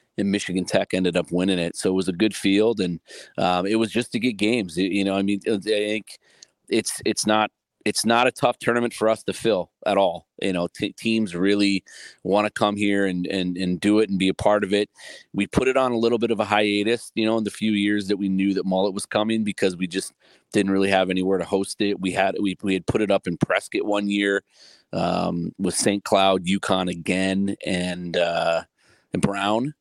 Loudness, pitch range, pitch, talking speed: -23 LUFS, 95-110 Hz, 100 Hz, 230 wpm